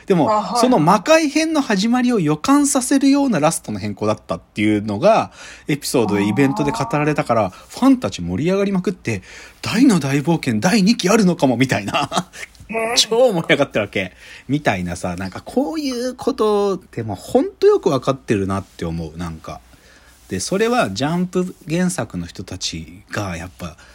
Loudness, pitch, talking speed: -18 LUFS, 155 Hz, 365 characters per minute